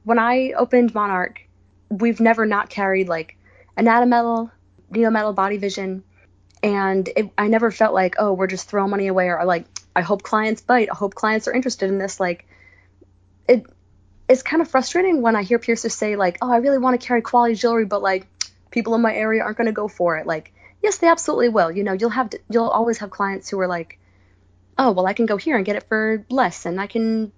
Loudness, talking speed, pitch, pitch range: -20 LUFS, 225 wpm, 210 Hz, 185-235 Hz